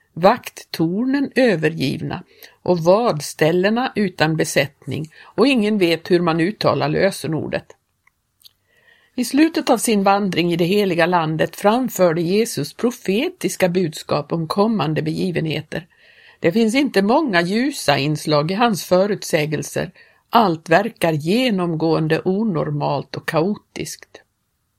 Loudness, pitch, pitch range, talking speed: -19 LUFS, 185 Hz, 165-225 Hz, 105 wpm